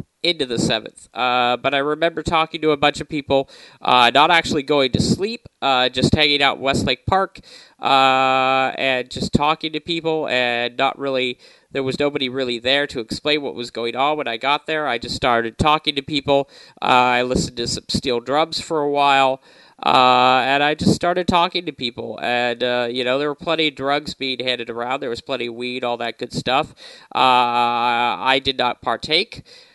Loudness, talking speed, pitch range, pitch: -19 LUFS, 200 wpm, 125-150 Hz, 135 Hz